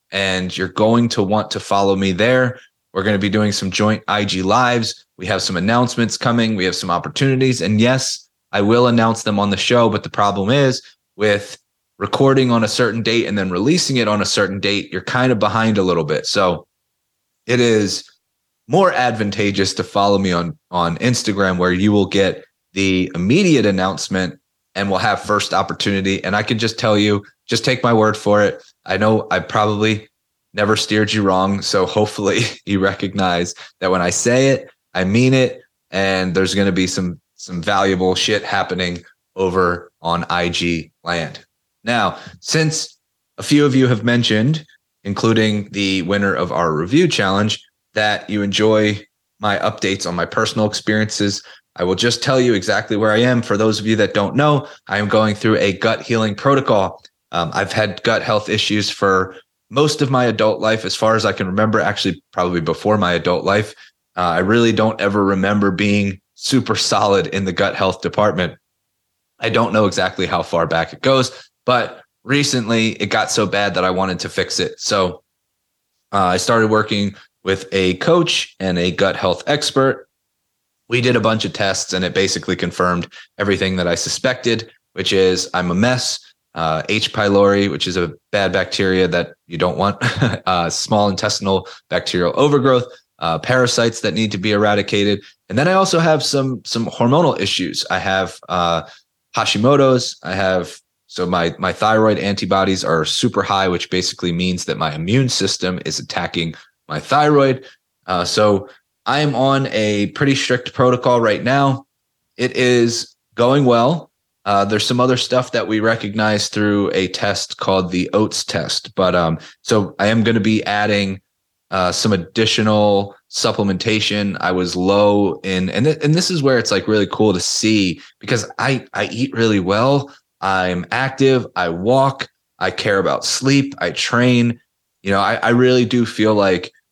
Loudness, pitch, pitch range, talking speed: -17 LUFS, 105 Hz, 95-120 Hz, 180 wpm